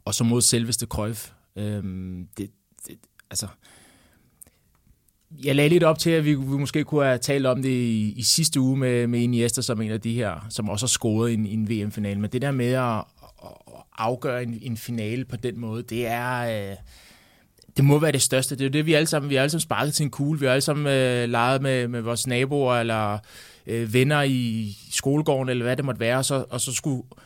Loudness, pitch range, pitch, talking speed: -23 LUFS, 115-135 Hz, 125 Hz, 225 wpm